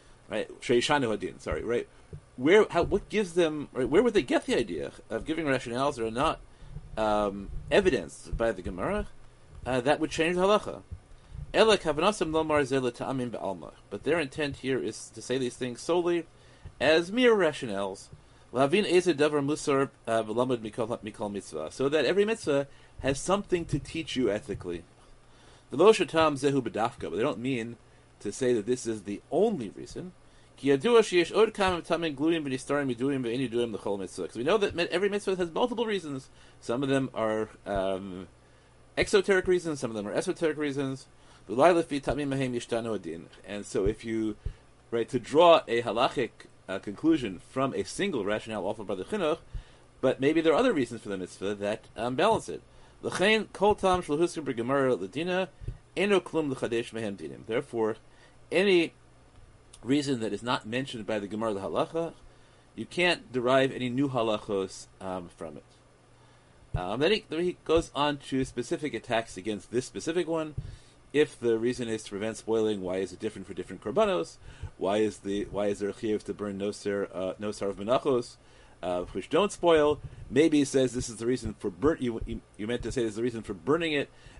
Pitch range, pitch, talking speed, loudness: 110-160 Hz, 130 Hz, 150 wpm, -28 LUFS